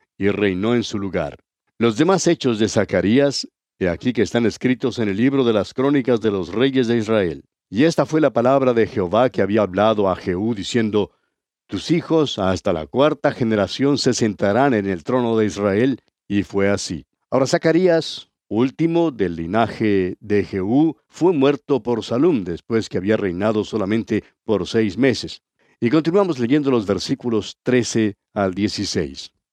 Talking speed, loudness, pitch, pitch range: 165 wpm, -19 LUFS, 115 Hz, 100-135 Hz